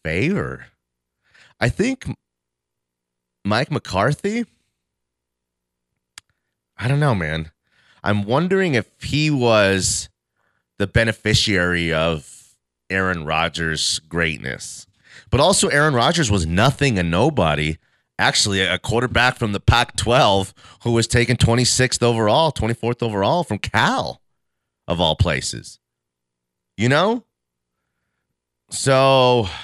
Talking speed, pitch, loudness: 100 wpm, 95 Hz, -19 LUFS